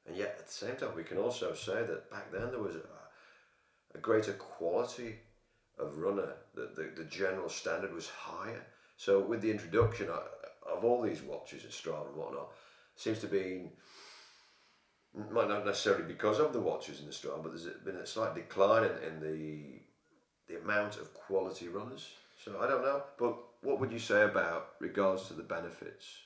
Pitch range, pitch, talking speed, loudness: 95-120 Hz, 110 Hz, 185 wpm, -36 LUFS